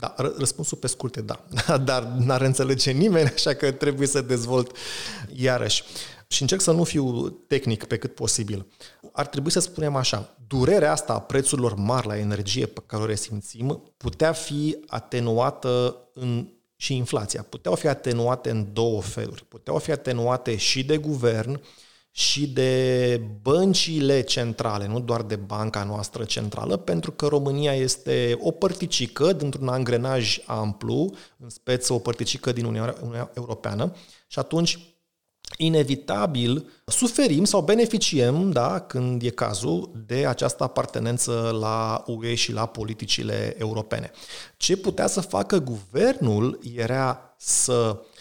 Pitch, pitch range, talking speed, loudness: 125 Hz, 115-145 Hz, 135 wpm, -24 LUFS